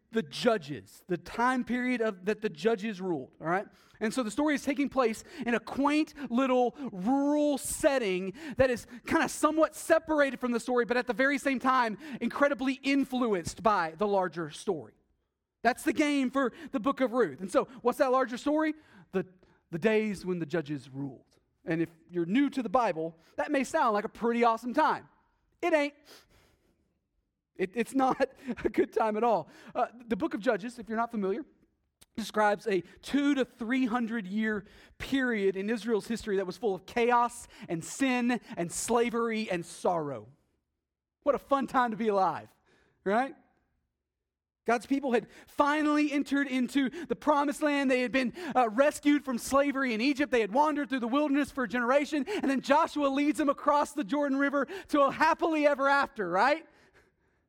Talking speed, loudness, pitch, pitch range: 180 wpm, -29 LUFS, 250 Hz, 220-285 Hz